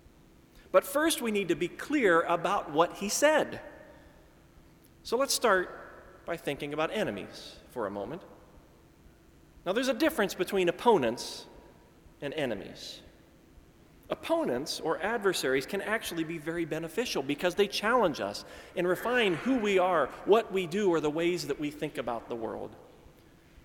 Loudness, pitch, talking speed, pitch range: -30 LUFS, 180 Hz, 145 wpm, 165-220 Hz